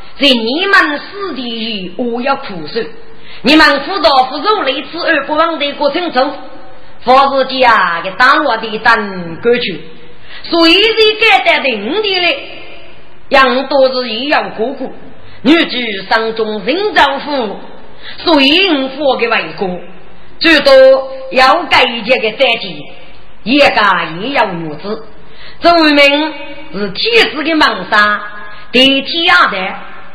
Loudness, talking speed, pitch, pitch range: -10 LUFS, 185 characters per minute, 265 Hz, 225-305 Hz